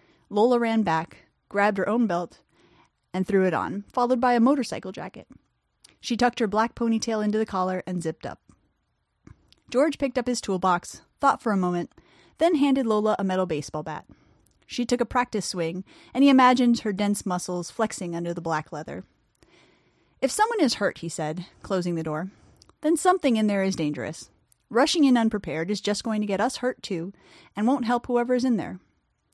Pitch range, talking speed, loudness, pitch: 180-245 Hz, 190 wpm, -25 LUFS, 210 Hz